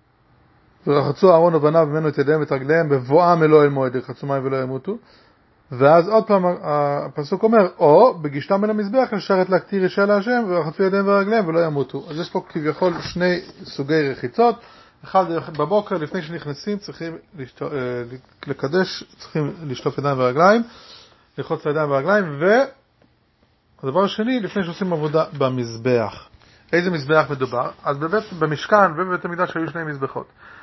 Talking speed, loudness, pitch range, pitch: 140 wpm, -19 LUFS, 140-190 Hz, 160 Hz